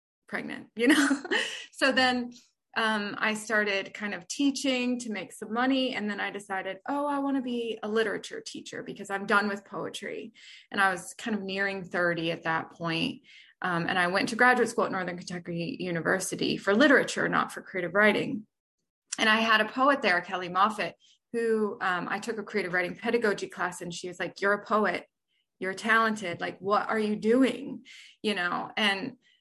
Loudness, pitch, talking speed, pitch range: -28 LUFS, 215 Hz, 190 wpm, 190-250 Hz